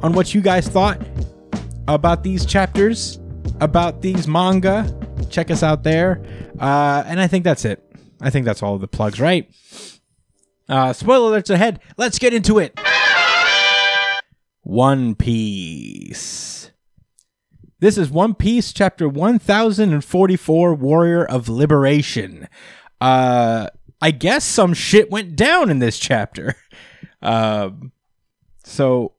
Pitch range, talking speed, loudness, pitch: 125-195 Hz, 125 wpm, -16 LUFS, 160 Hz